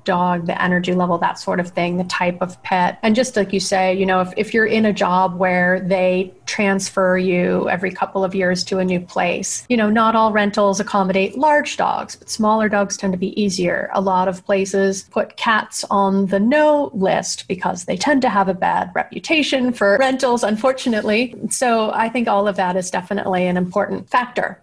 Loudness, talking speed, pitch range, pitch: -18 LUFS, 205 wpm, 185-220 Hz, 195 Hz